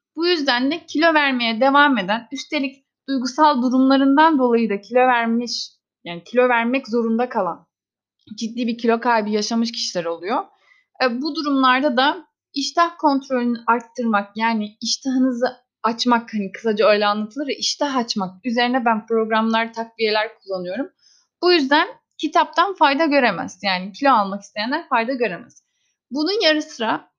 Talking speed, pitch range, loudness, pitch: 135 wpm, 225-290 Hz, -19 LUFS, 250 Hz